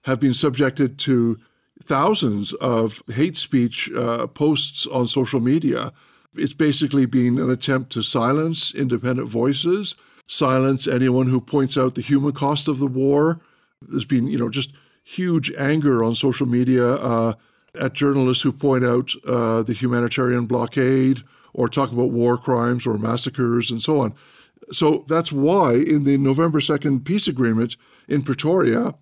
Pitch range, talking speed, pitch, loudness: 120-145 Hz, 155 wpm, 130 Hz, -20 LUFS